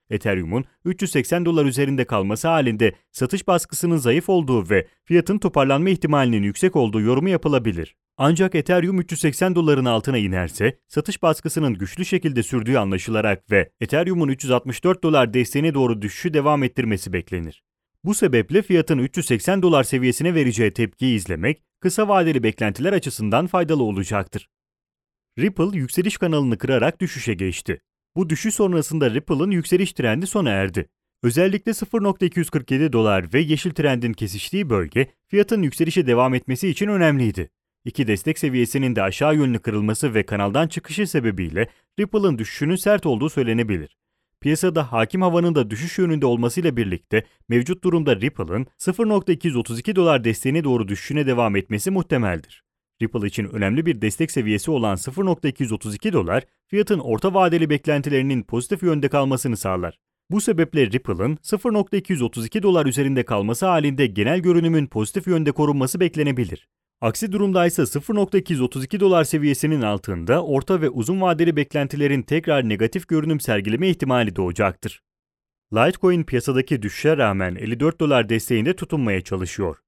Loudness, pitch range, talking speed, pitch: -21 LUFS, 115-175 Hz, 130 wpm, 140 Hz